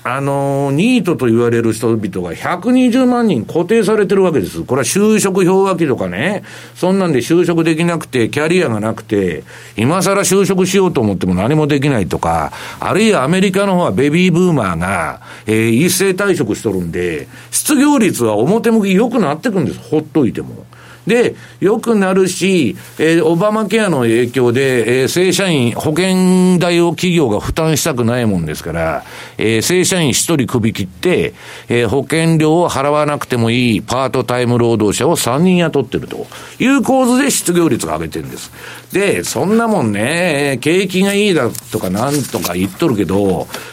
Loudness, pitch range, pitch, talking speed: -14 LUFS, 120-185 Hz, 155 Hz, 345 characters per minute